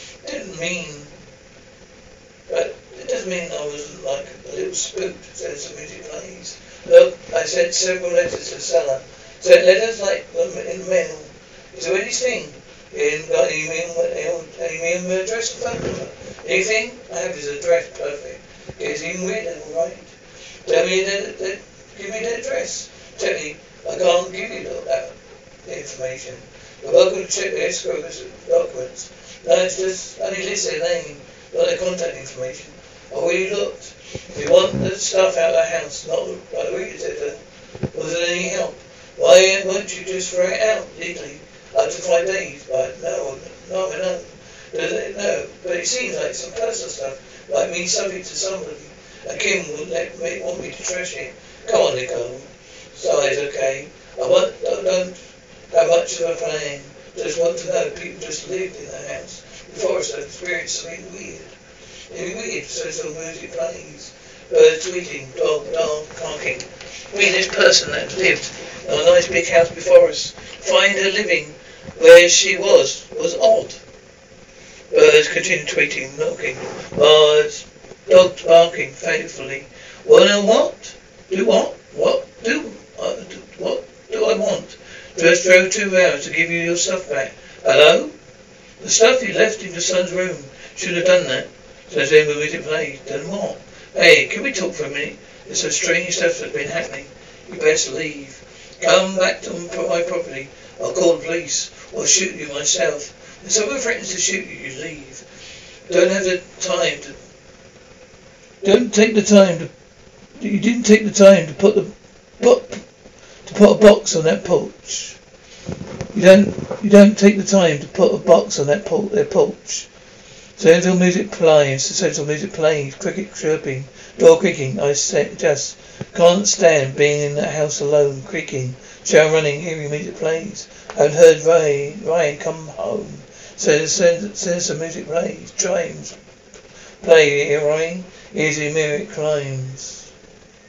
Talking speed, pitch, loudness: 165 wpm, 195 Hz, -17 LUFS